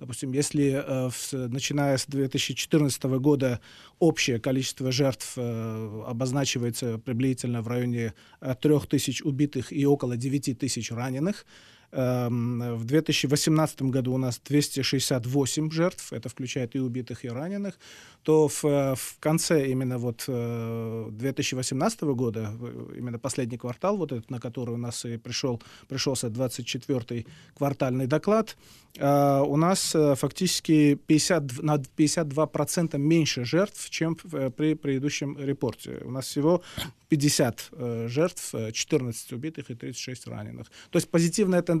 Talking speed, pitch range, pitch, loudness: 115 wpm, 125-150 Hz, 135 Hz, -27 LUFS